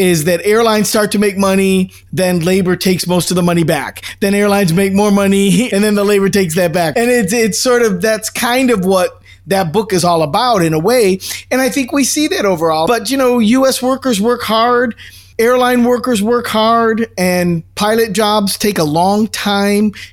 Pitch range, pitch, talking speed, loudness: 185-230 Hz, 205 Hz, 205 wpm, -13 LUFS